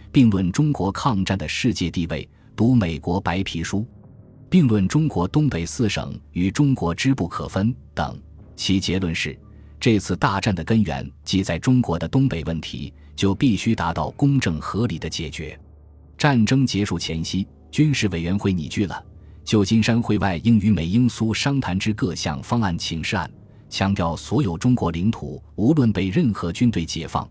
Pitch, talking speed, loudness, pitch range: 95 Hz, 255 characters per minute, -22 LUFS, 85-120 Hz